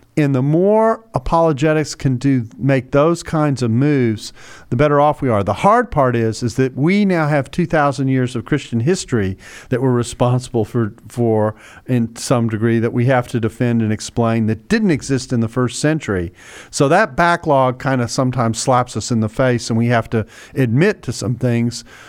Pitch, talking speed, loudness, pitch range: 125 Hz, 195 wpm, -17 LUFS, 115-145 Hz